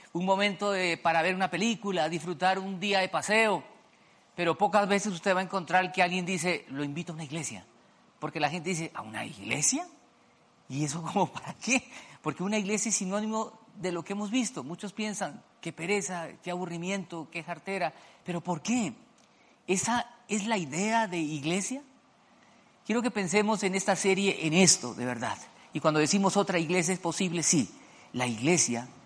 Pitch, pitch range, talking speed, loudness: 190 Hz, 170-210 Hz, 180 wpm, -29 LUFS